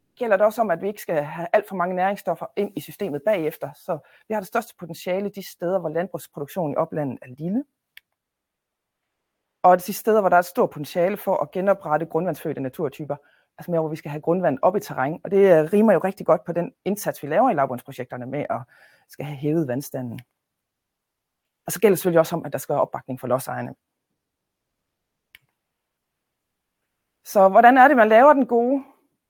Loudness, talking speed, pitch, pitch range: -21 LUFS, 200 wpm, 175 Hz, 150-200 Hz